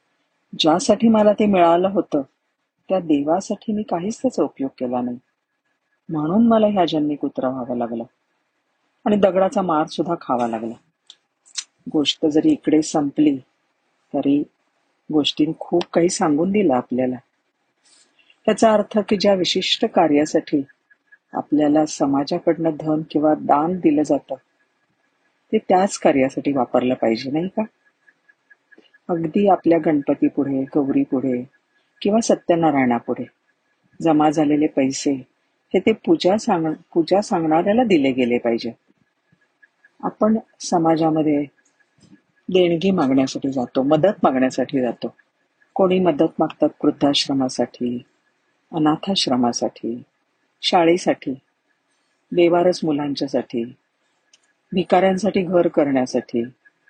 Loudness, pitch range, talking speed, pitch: -19 LUFS, 140-205 Hz, 100 wpm, 165 Hz